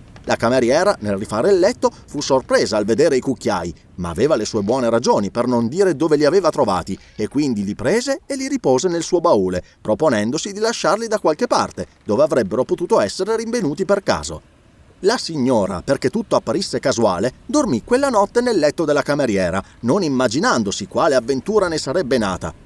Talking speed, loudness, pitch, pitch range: 180 wpm, -18 LUFS, 180 Hz, 140-225 Hz